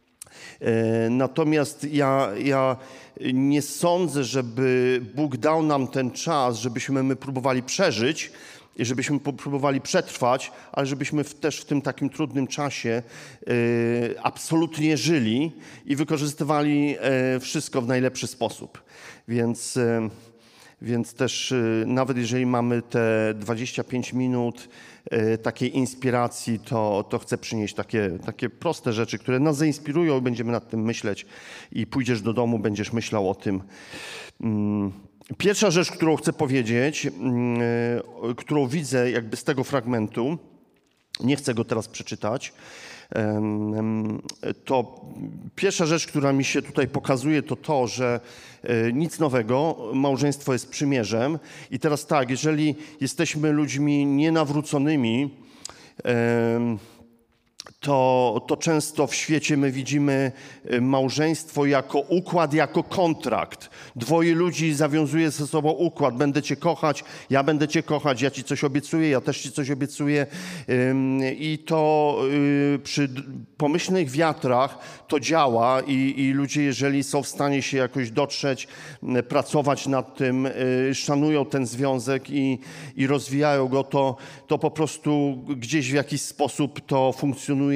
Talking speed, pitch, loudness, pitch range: 120 wpm, 135 Hz, -24 LUFS, 120-150 Hz